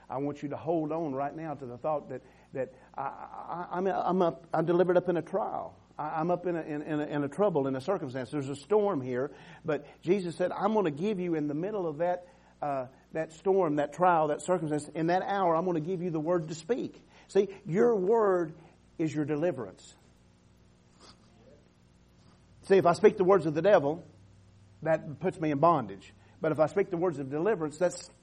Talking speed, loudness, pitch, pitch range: 220 wpm, -30 LUFS, 160 Hz, 145-180 Hz